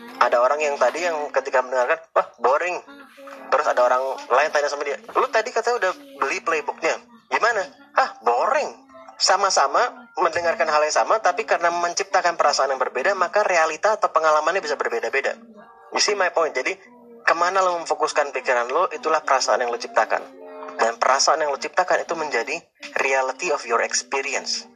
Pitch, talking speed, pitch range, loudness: 160 Hz, 165 wpm, 135-190 Hz, -21 LUFS